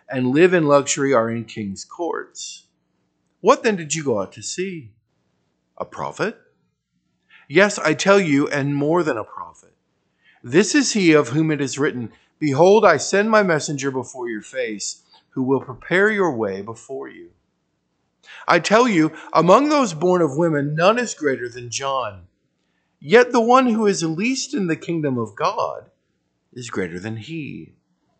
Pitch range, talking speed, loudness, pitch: 125-195 Hz, 165 wpm, -19 LUFS, 155 Hz